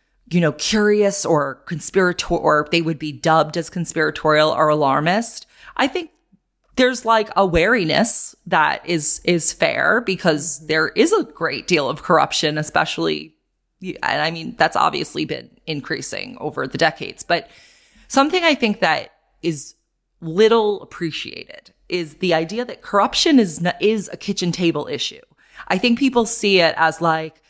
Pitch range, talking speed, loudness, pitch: 155-210 Hz, 155 wpm, -18 LUFS, 170 Hz